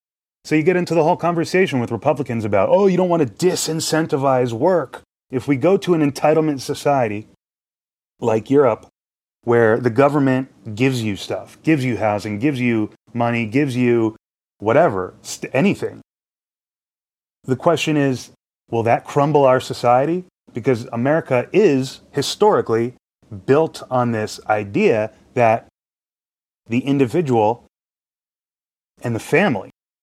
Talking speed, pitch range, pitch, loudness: 130 wpm, 115-155 Hz, 130 Hz, -18 LUFS